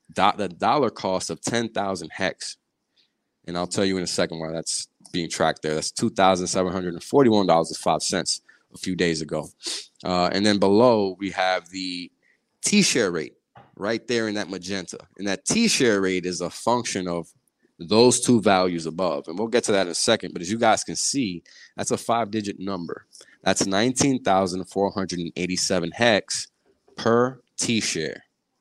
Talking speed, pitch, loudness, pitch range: 165 wpm, 95 Hz, -23 LUFS, 90-105 Hz